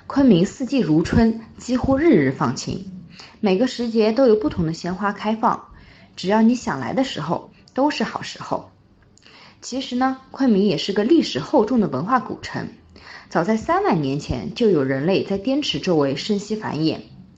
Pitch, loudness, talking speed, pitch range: 220 Hz, -20 LUFS, 255 characters per minute, 185-255 Hz